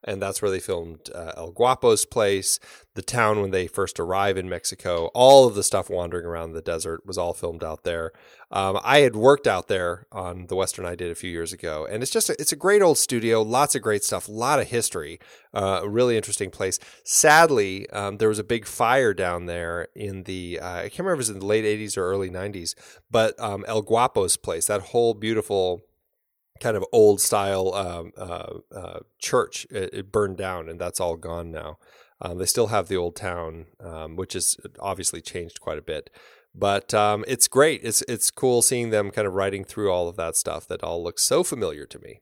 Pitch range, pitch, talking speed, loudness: 90-110 Hz, 100 Hz, 220 wpm, -23 LUFS